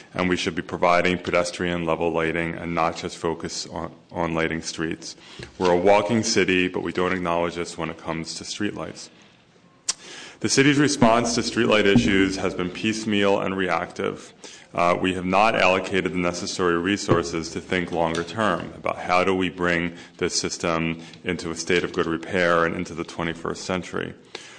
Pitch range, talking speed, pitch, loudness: 85-95 Hz, 175 wpm, 90 Hz, -23 LUFS